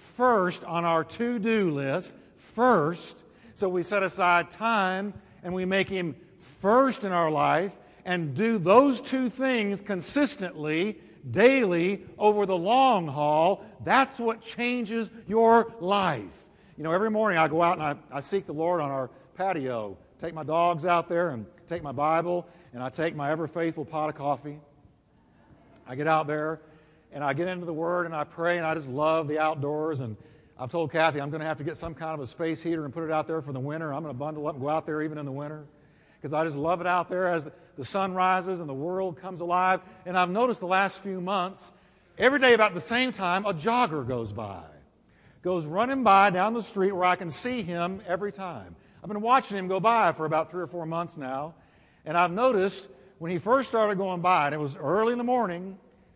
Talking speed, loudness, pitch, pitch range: 215 wpm, -26 LUFS, 175 Hz, 155-195 Hz